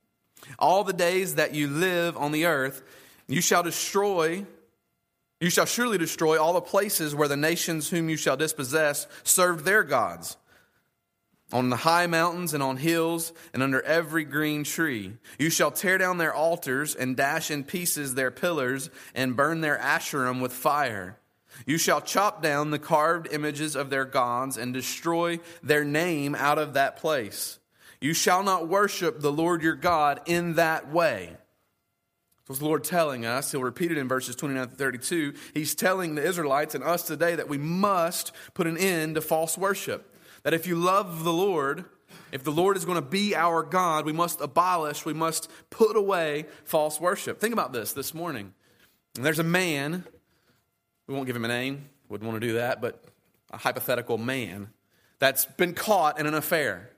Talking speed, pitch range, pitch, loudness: 180 wpm, 140-170 Hz, 155 Hz, -26 LUFS